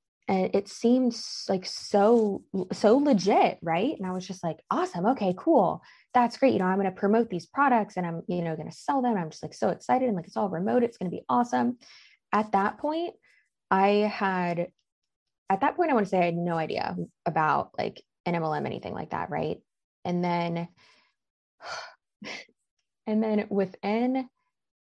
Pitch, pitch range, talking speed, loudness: 195 Hz, 175-235 Hz, 190 wpm, -27 LUFS